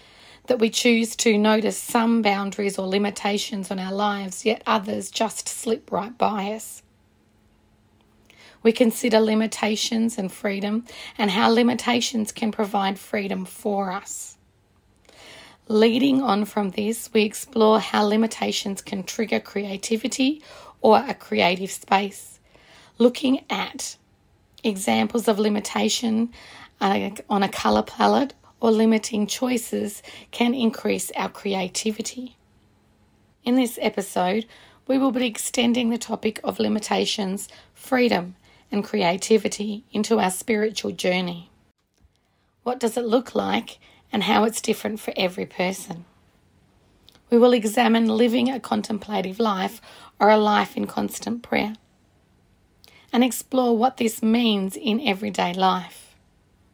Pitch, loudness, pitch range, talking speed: 215 Hz, -23 LUFS, 190-230 Hz, 120 wpm